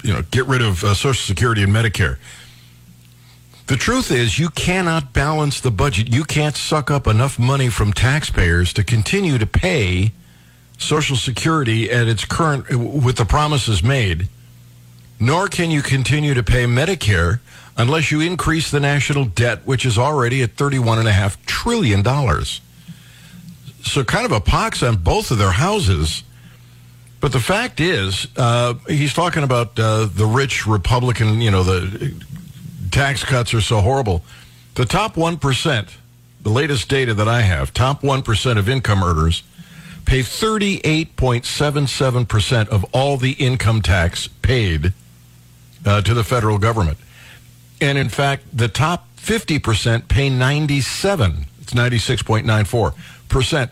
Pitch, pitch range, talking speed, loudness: 120 Hz, 100-140 Hz, 145 wpm, -17 LUFS